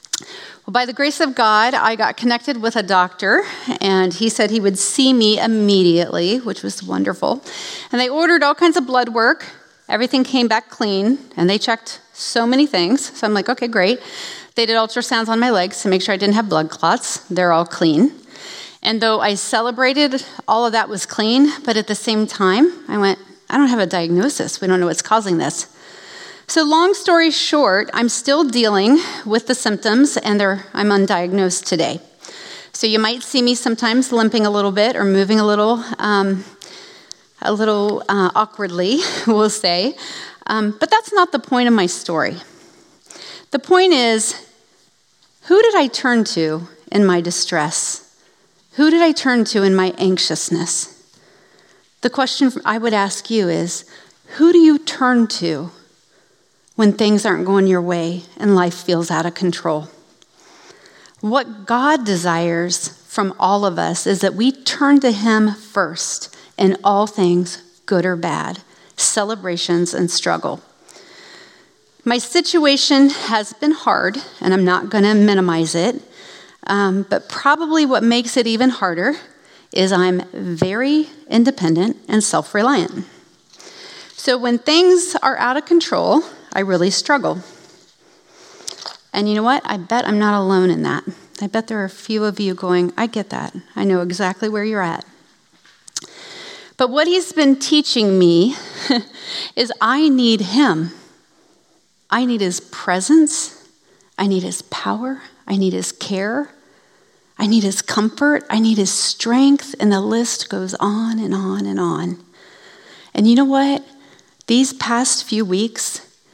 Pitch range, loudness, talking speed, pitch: 190-270 Hz, -16 LUFS, 160 wpm, 220 Hz